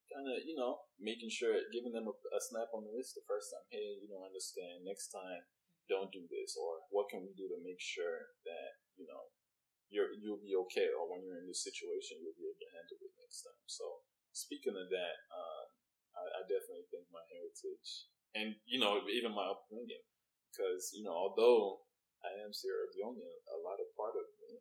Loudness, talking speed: -42 LUFS, 210 wpm